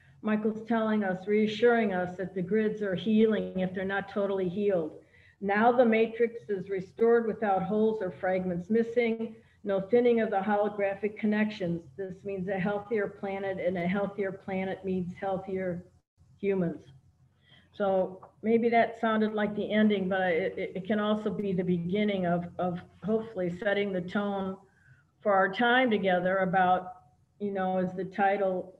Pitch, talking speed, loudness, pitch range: 195 Hz, 155 wpm, -29 LUFS, 185-215 Hz